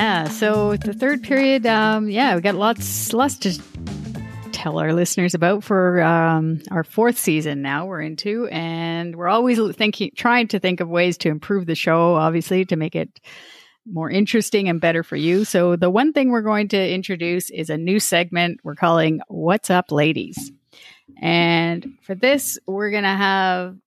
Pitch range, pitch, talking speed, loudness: 165-215 Hz, 180 Hz, 175 wpm, -19 LUFS